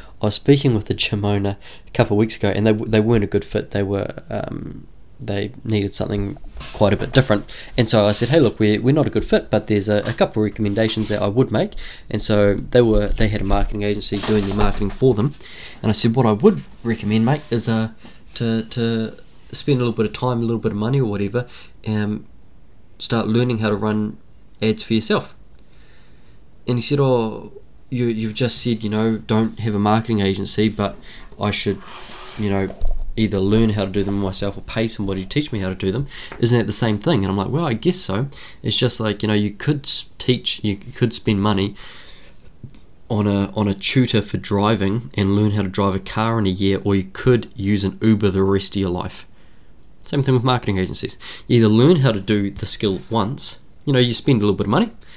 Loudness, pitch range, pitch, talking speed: -19 LUFS, 100-120 Hz, 110 Hz, 230 wpm